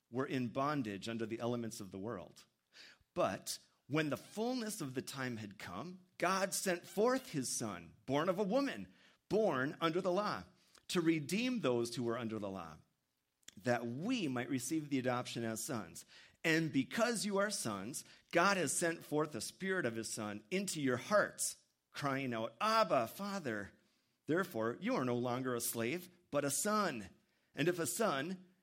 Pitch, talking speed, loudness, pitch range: 140 Hz, 170 wpm, -38 LUFS, 115-185 Hz